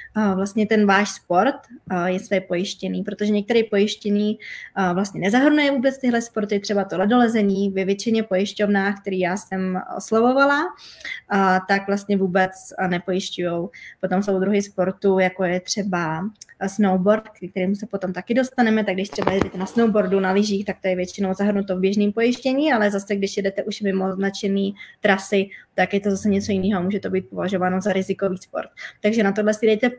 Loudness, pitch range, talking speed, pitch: -21 LUFS, 190-210 Hz, 170 wpm, 195 Hz